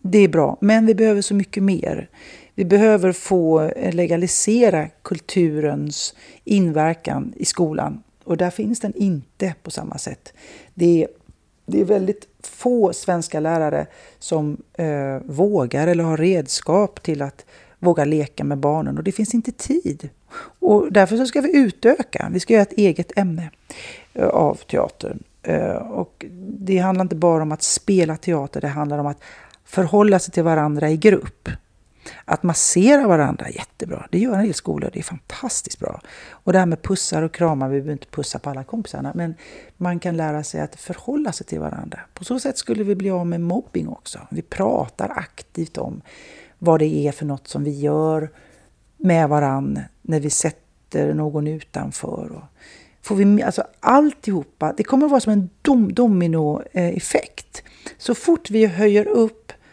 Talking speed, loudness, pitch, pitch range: 170 wpm, -19 LUFS, 180 Hz, 155-210 Hz